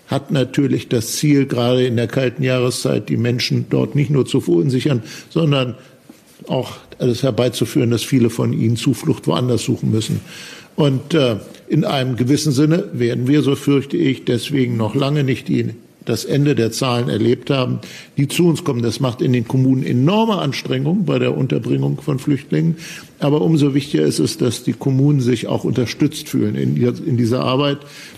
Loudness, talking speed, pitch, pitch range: -18 LUFS, 175 wpm, 130 Hz, 120-145 Hz